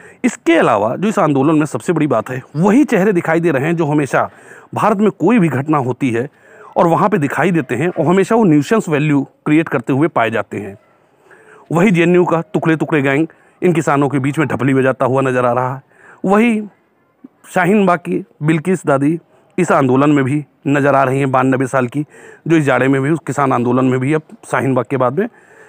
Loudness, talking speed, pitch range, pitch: -15 LUFS, 215 wpm, 135-180 Hz, 155 Hz